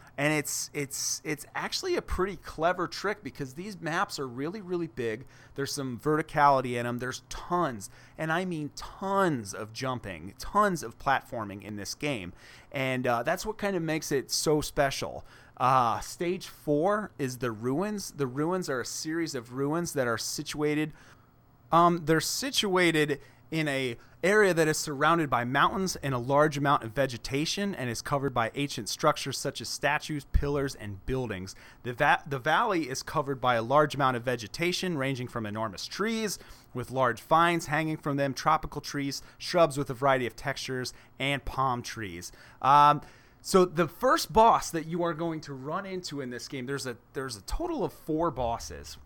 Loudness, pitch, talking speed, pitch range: -29 LUFS, 140 Hz, 180 wpm, 125-160 Hz